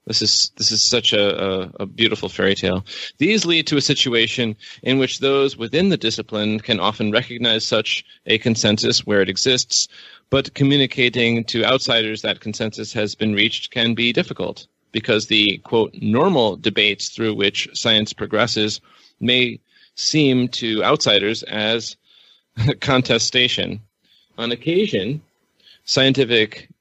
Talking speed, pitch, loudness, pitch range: 135 wpm, 115 Hz, -18 LUFS, 105-130 Hz